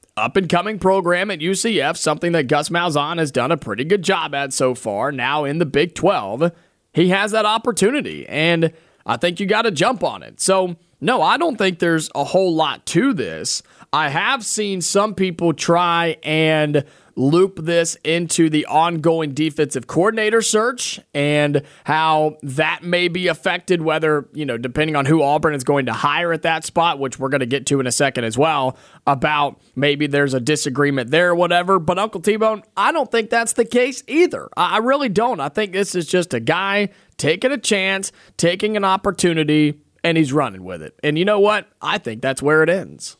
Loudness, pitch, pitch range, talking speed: -18 LUFS, 170 Hz, 150-195 Hz, 195 wpm